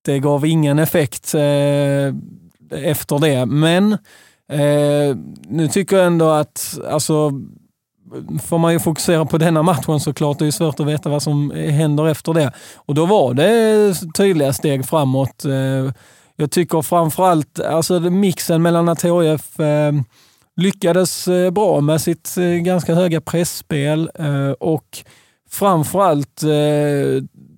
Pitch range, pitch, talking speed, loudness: 145-170 Hz, 155 Hz, 140 wpm, -17 LUFS